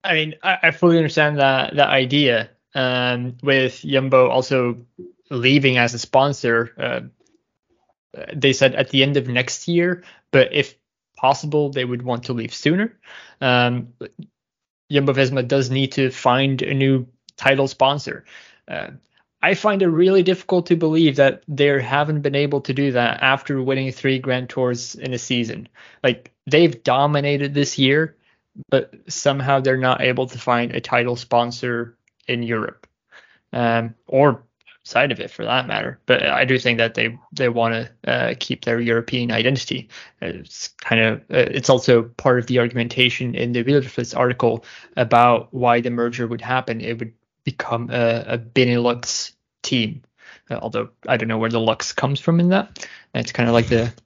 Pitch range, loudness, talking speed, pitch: 120-140 Hz, -19 LUFS, 170 wpm, 130 Hz